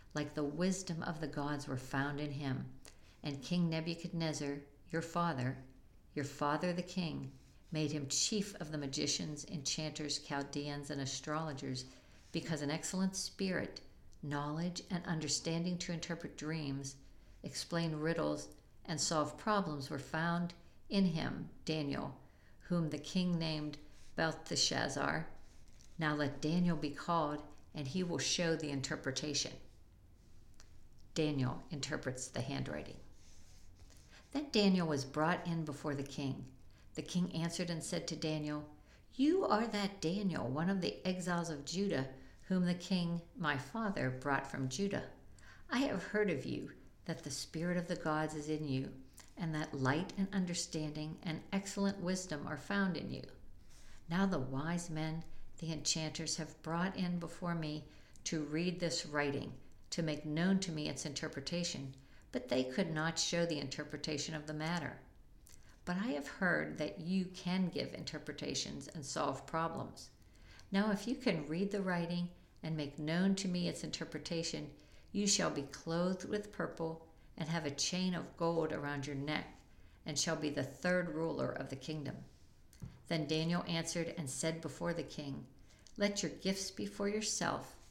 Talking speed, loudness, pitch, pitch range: 155 wpm, -38 LUFS, 155 Hz, 145-175 Hz